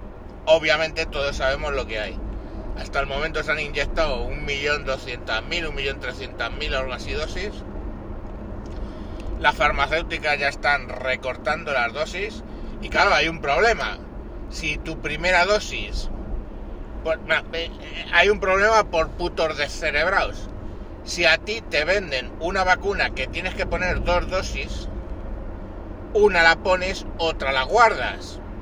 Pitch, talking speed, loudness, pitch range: 145 Hz, 130 wpm, -22 LUFS, 105-170 Hz